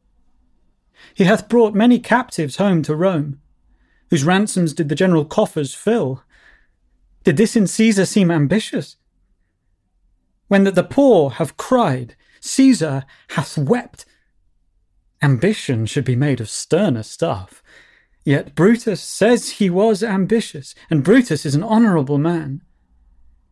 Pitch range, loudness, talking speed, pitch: 125-210 Hz, -17 LUFS, 125 wpm, 160 Hz